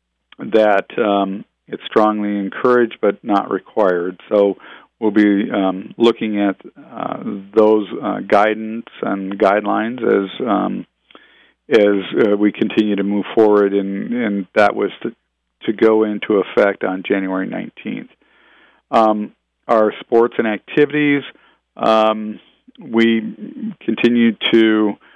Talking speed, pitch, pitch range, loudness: 120 wpm, 105 Hz, 100-115 Hz, -17 LUFS